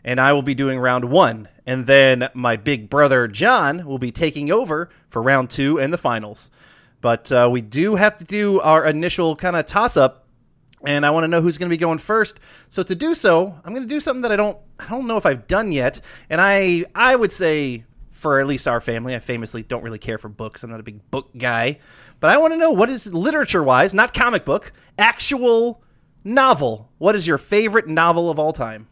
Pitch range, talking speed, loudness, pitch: 125-195 Hz, 230 wpm, -18 LUFS, 150 Hz